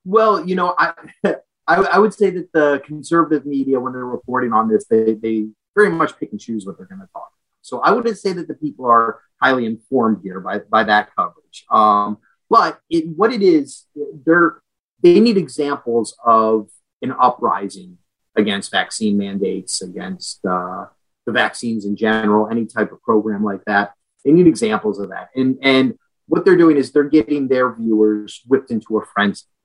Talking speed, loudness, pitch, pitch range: 185 wpm, -17 LUFS, 125 Hz, 105-160 Hz